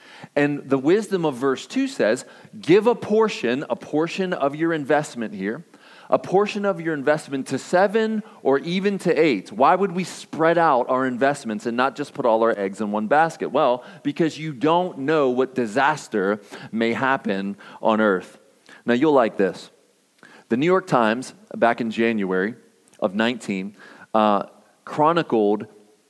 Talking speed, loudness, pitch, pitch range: 160 wpm, -22 LUFS, 140 Hz, 115-175 Hz